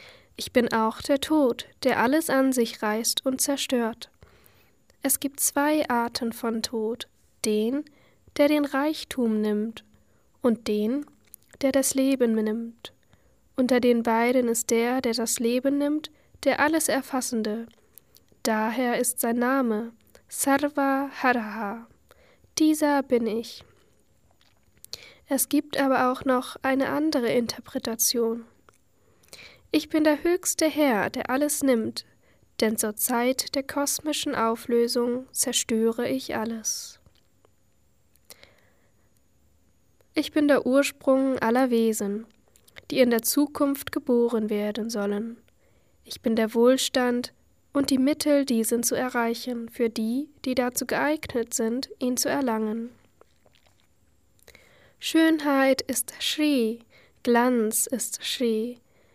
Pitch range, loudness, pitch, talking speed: 230-280 Hz, -25 LUFS, 250 Hz, 115 wpm